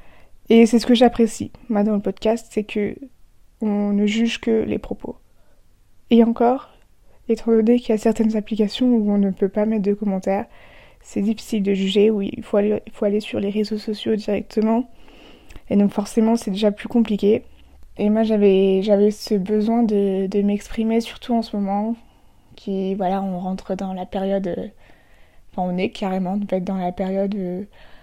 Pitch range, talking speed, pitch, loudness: 195-225 Hz, 180 wpm, 205 Hz, -20 LUFS